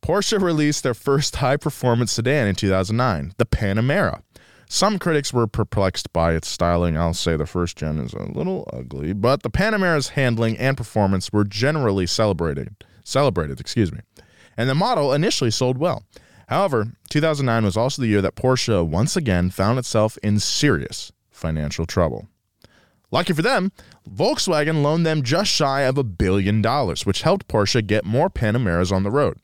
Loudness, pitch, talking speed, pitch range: -21 LUFS, 115 Hz, 165 wpm, 95-145 Hz